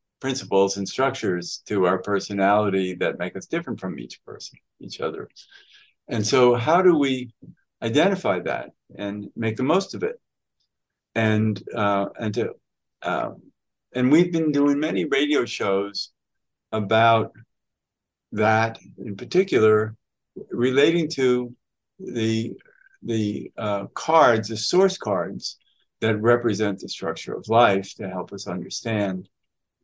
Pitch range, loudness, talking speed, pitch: 100-125 Hz, -23 LUFS, 125 wpm, 110 Hz